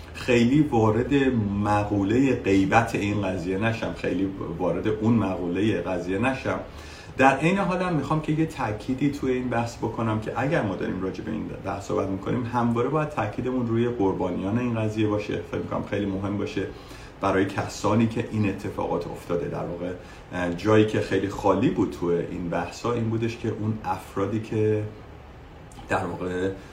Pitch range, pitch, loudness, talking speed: 95-120 Hz, 105 Hz, -25 LUFS, 160 wpm